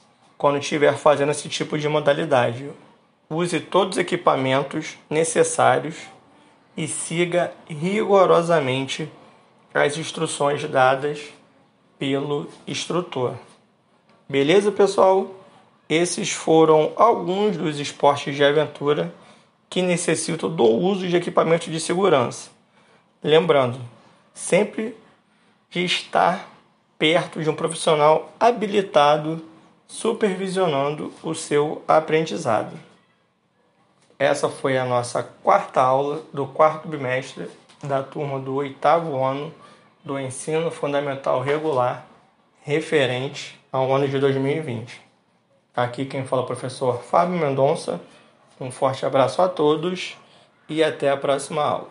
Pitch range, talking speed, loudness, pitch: 140-175 Hz, 105 wpm, -21 LUFS, 155 Hz